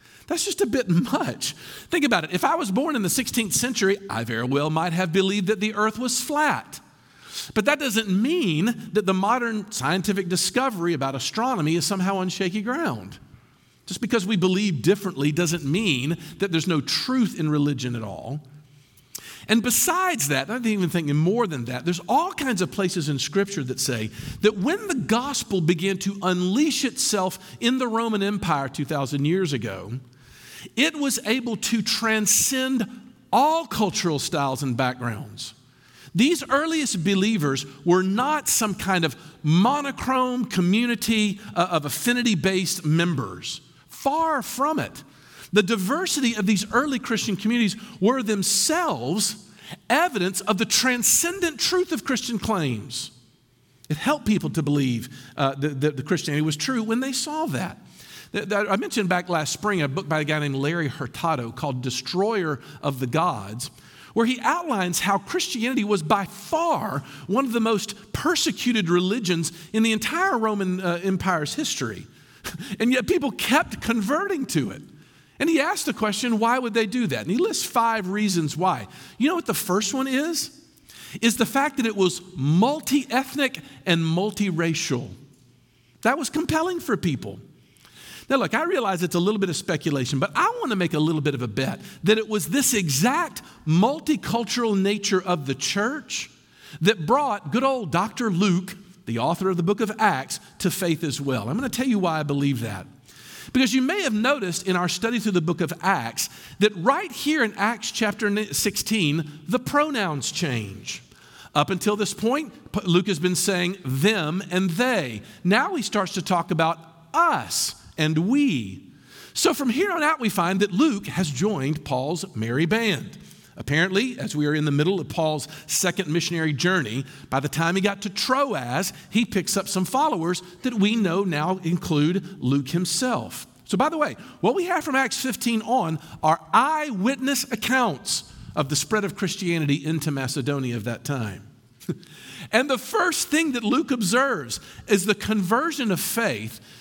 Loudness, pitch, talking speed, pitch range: -23 LUFS, 195 Hz, 170 wpm, 160-235 Hz